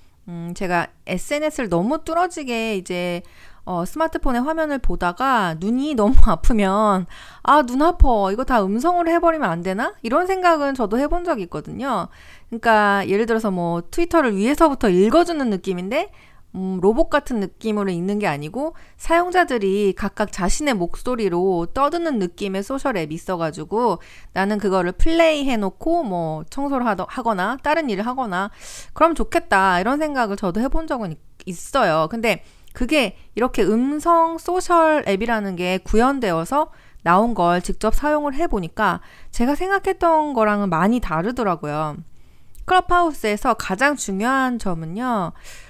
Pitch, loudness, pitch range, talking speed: 225 Hz, -20 LUFS, 190-295 Hz, 325 characters per minute